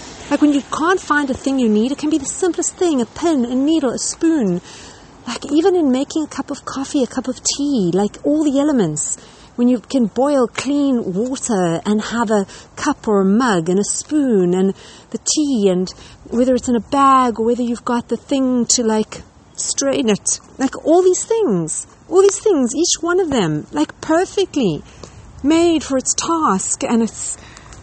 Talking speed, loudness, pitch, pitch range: 195 wpm, -17 LUFS, 260 Hz, 220-300 Hz